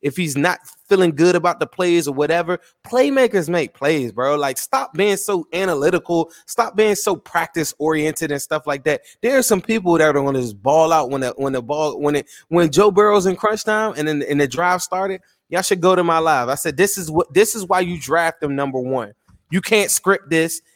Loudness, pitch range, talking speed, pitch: -18 LUFS, 150-195 Hz, 230 wpm, 170 Hz